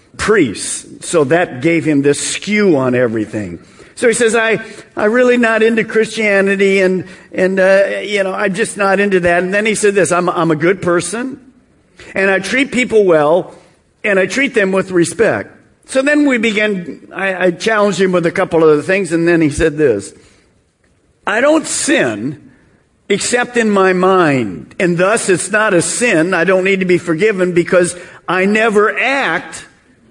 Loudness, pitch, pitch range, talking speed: -13 LUFS, 190 Hz, 175-220 Hz, 180 wpm